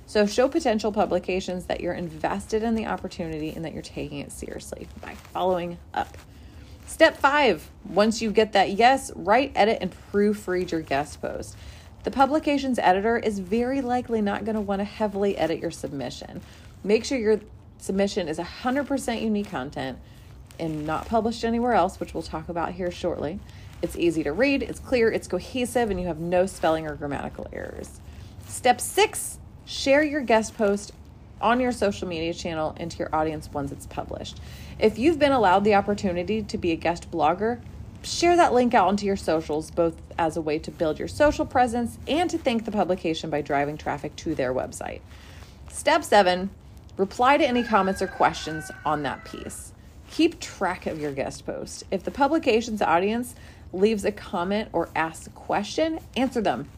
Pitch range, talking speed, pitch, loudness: 170-245 Hz, 175 wpm, 205 Hz, -25 LUFS